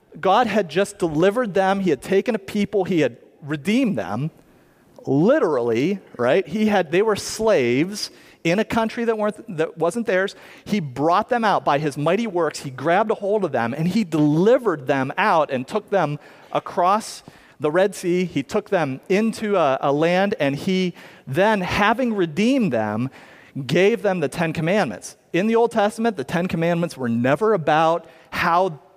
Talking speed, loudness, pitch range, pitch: 175 wpm, -21 LUFS, 155-210 Hz, 185 Hz